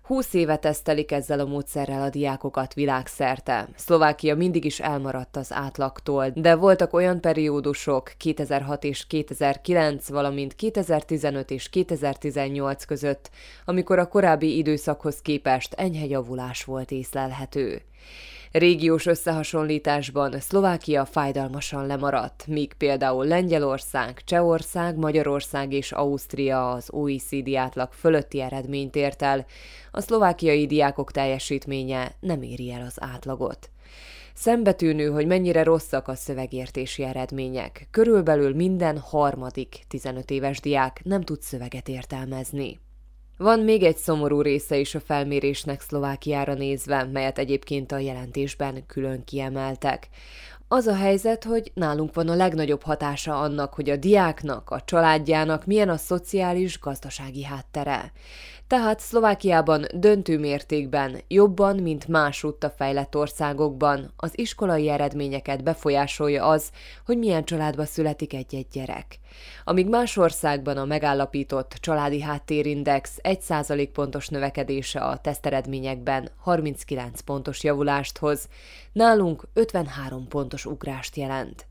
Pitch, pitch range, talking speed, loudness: 145 Hz, 135-160 Hz, 115 wpm, -24 LUFS